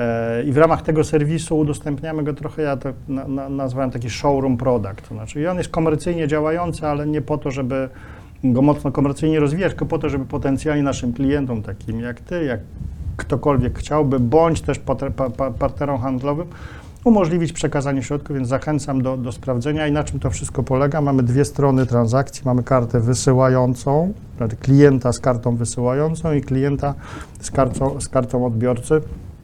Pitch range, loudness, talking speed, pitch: 125-150 Hz, -20 LUFS, 160 wpm, 135 Hz